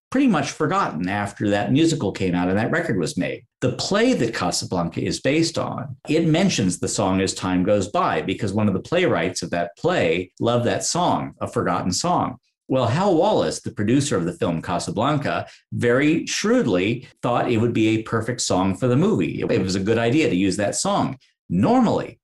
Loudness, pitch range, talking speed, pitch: -21 LUFS, 95-130 Hz, 195 wpm, 115 Hz